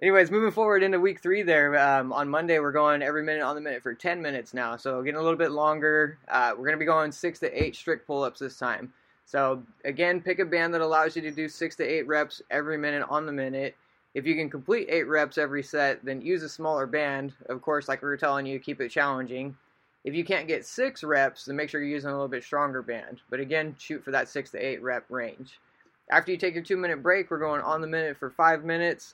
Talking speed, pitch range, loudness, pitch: 255 wpm, 140-165 Hz, -27 LUFS, 150 Hz